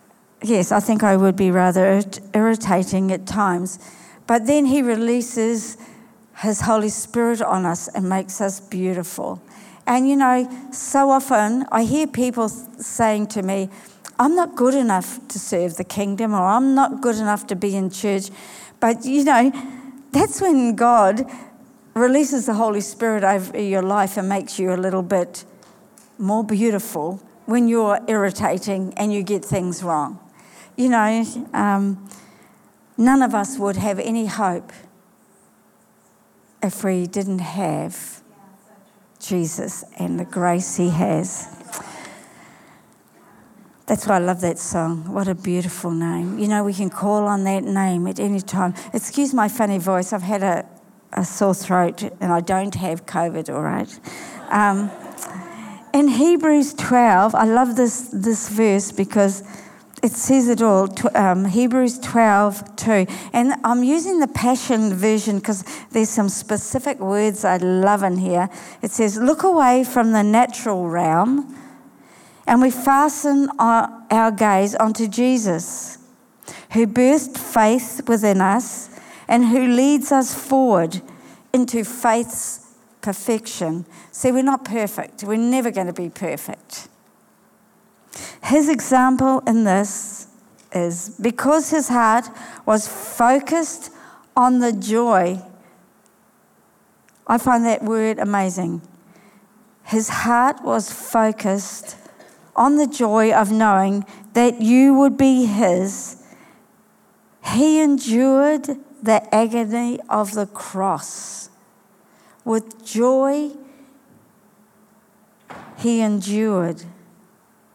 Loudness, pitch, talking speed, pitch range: -19 LUFS, 215 Hz, 130 wpm, 195-245 Hz